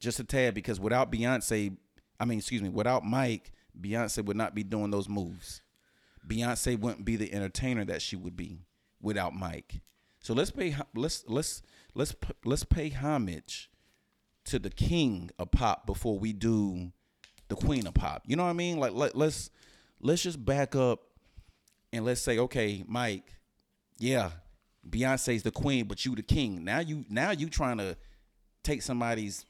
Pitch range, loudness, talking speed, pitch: 95-125 Hz, -32 LUFS, 170 wpm, 110 Hz